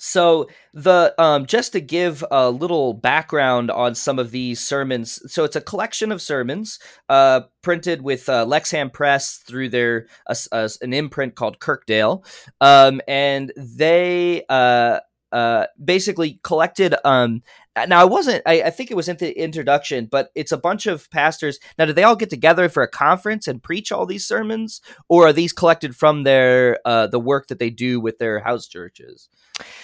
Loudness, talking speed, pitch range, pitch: -18 LUFS, 180 wpm, 125-175 Hz, 145 Hz